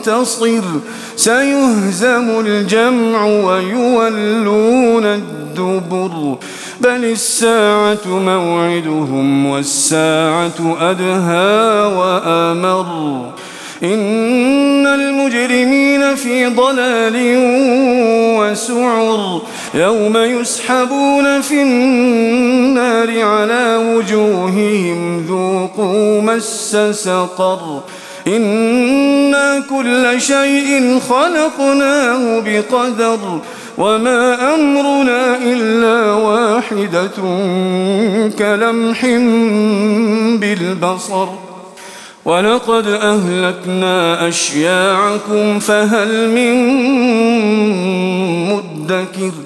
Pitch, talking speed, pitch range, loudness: 220 Hz, 50 wpm, 185-245 Hz, -13 LUFS